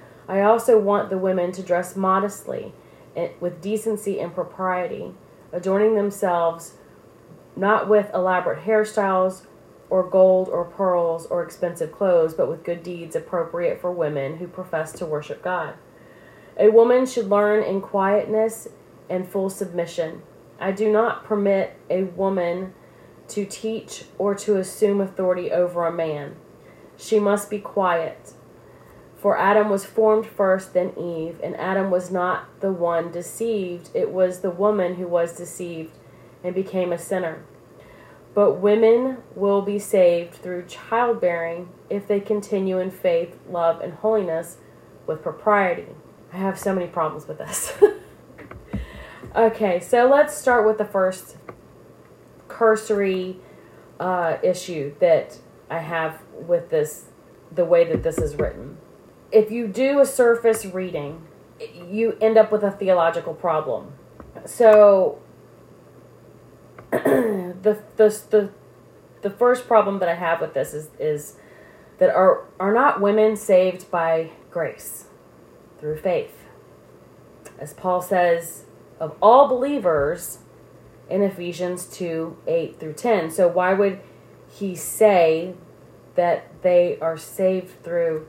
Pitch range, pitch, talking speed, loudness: 175-215 Hz, 190 Hz, 135 wpm, -21 LUFS